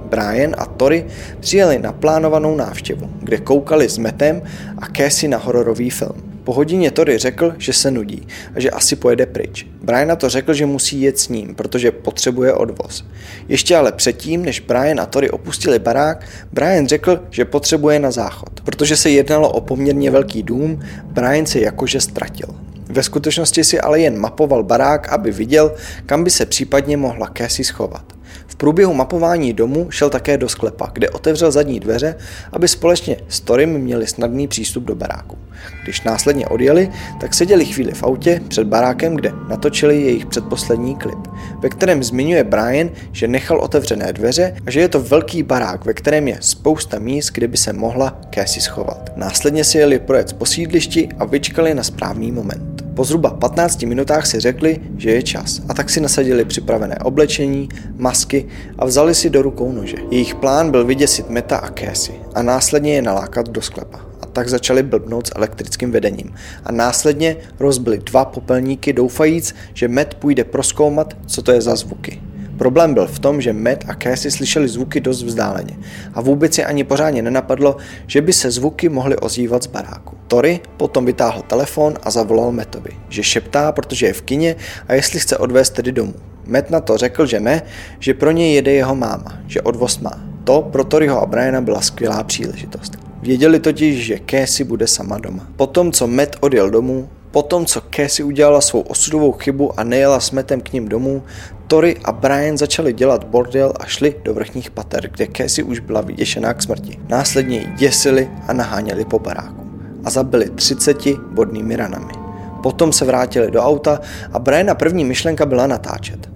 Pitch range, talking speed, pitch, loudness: 115-150 Hz, 175 wpm, 130 Hz, -15 LUFS